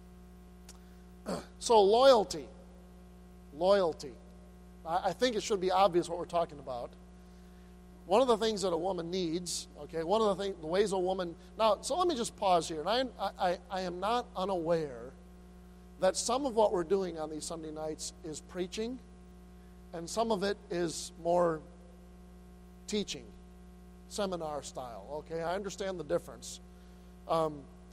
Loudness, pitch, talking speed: -32 LUFS, 160 Hz, 155 wpm